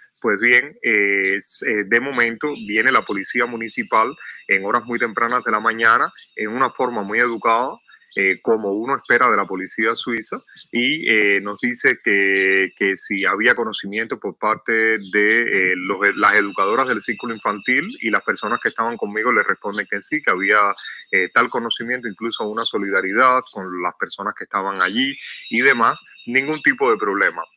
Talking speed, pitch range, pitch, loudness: 170 wpm, 100-125 Hz, 115 Hz, -18 LUFS